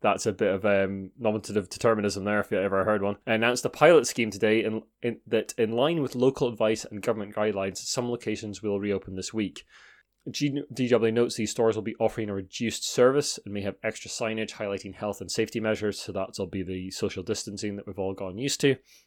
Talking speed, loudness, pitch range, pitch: 215 wpm, -27 LUFS, 100-115 Hz, 110 Hz